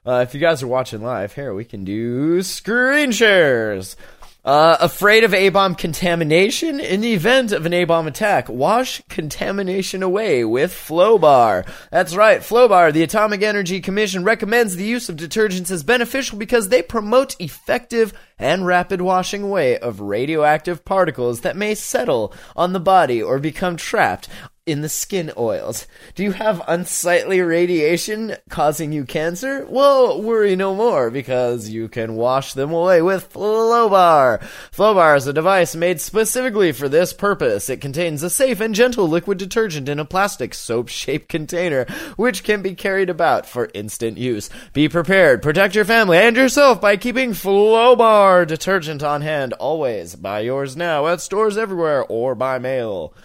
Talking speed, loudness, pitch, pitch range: 160 wpm, -17 LUFS, 185 Hz, 155-215 Hz